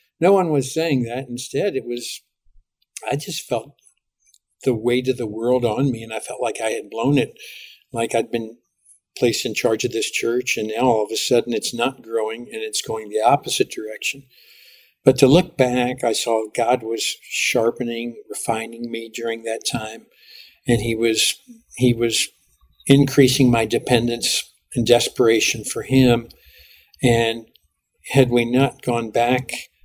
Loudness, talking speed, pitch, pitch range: -20 LUFS, 165 wpm, 120 Hz, 115-130 Hz